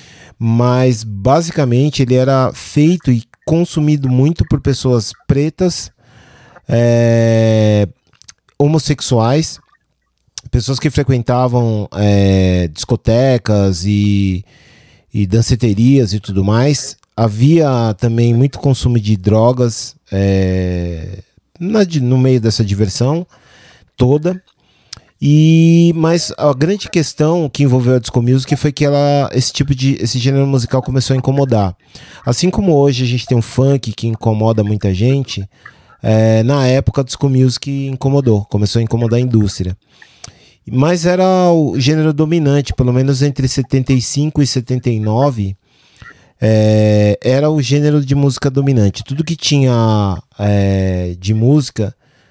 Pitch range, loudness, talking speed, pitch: 110-145 Hz, -13 LUFS, 125 wpm, 125 Hz